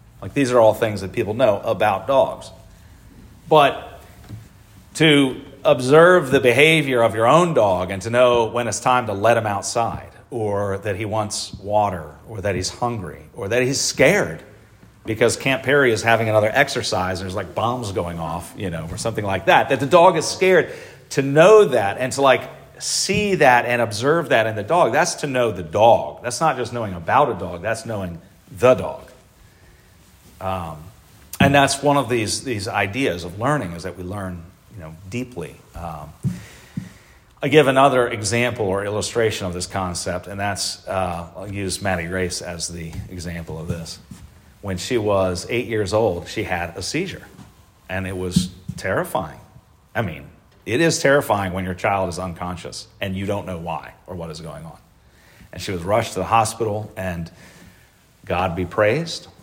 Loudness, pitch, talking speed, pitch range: -19 LUFS, 105 Hz, 180 wpm, 90-120 Hz